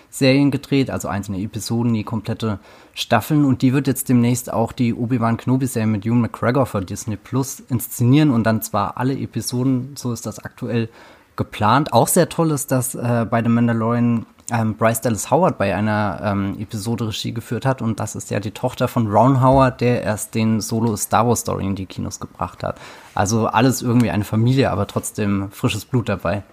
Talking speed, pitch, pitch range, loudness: 195 wpm, 115 Hz, 105-125 Hz, -19 LUFS